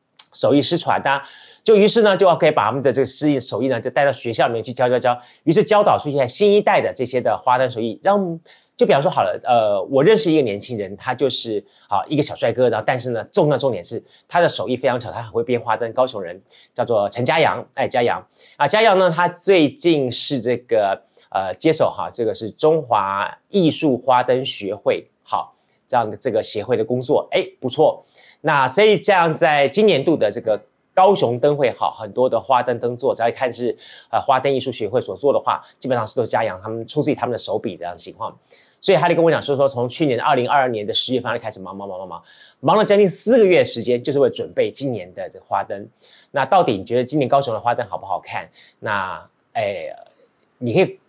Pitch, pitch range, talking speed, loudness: 140 Hz, 120-185 Hz, 340 characters per minute, -18 LUFS